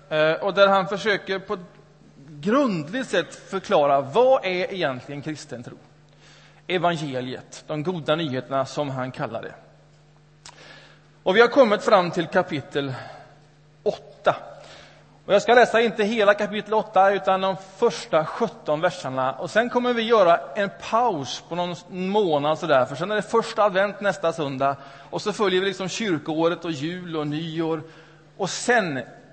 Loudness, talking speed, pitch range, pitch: -23 LUFS, 150 wpm, 150-200 Hz, 170 Hz